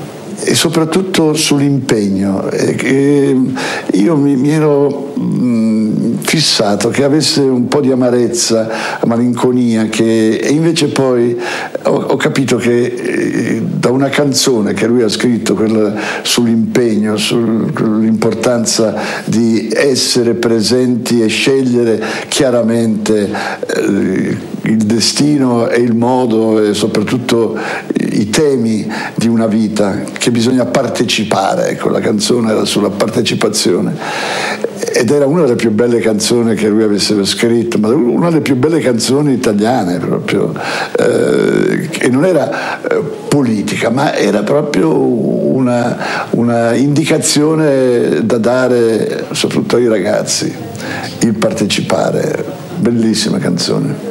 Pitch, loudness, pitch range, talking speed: 120 Hz, -12 LUFS, 110-135 Hz, 115 wpm